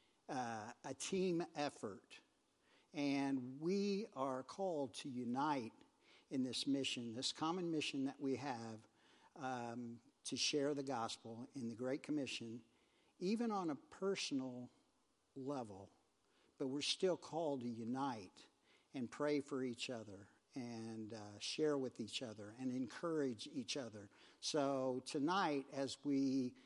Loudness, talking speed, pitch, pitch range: -43 LUFS, 130 wpm, 135 Hz, 120-145 Hz